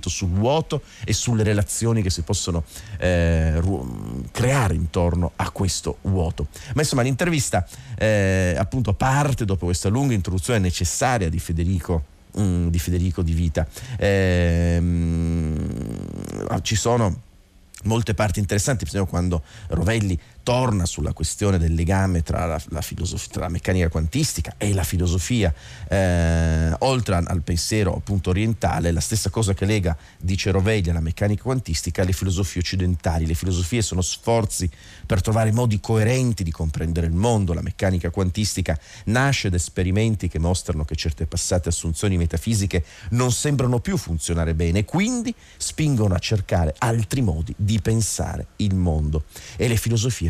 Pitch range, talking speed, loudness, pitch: 85-110 Hz, 140 wpm, -22 LUFS, 95 Hz